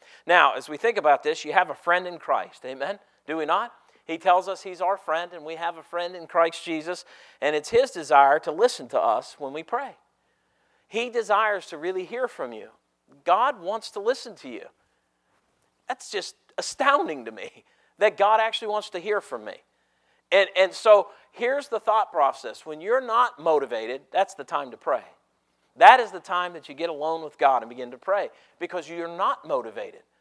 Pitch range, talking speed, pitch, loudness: 170-230 Hz, 200 wpm, 185 Hz, -24 LUFS